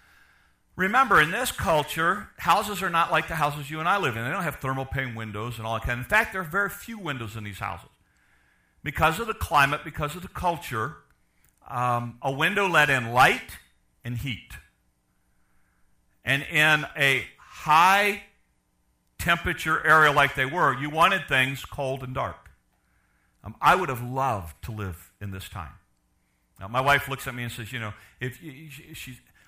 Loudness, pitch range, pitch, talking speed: -24 LUFS, 100-155 Hz, 130 Hz, 185 wpm